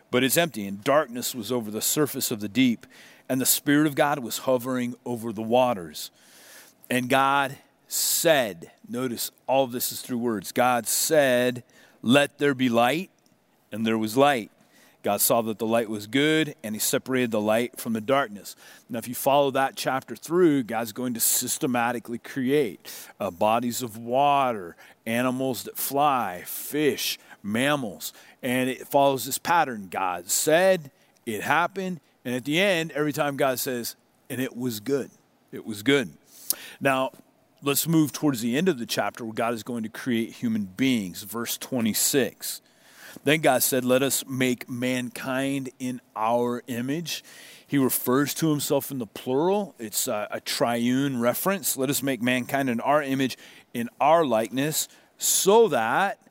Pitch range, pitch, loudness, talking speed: 120-140 Hz, 130 Hz, -25 LUFS, 165 wpm